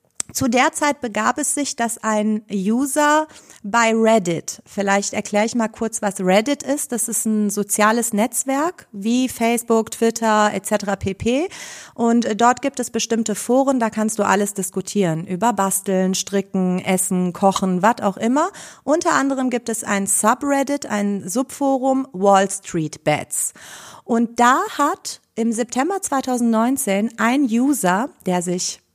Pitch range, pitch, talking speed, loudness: 200-260 Hz, 225 Hz, 145 wpm, -19 LUFS